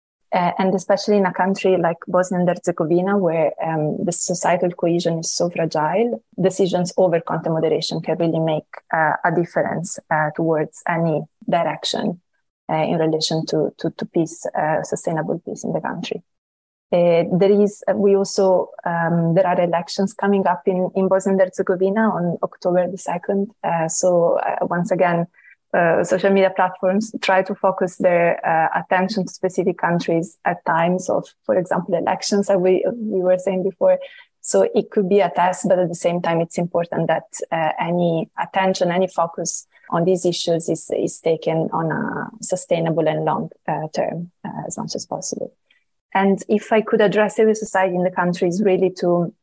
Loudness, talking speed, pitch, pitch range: -20 LUFS, 175 wpm, 180 Hz, 170-195 Hz